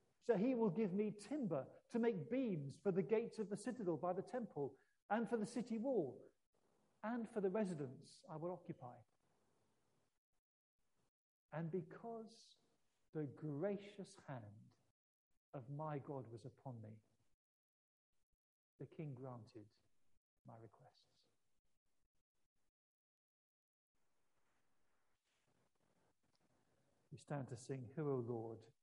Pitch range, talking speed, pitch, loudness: 130-210 Hz, 110 wpm, 160 Hz, -45 LUFS